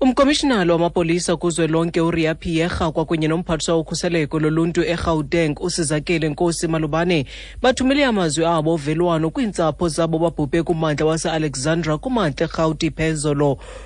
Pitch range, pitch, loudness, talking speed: 160-175 Hz, 165 Hz, -19 LUFS, 100 wpm